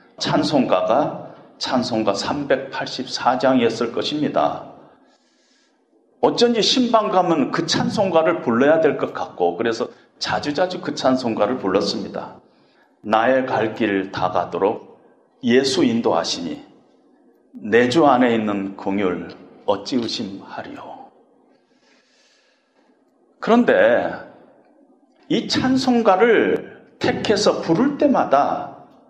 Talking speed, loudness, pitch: 200 characters per minute, -19 LUFS, 190 Hz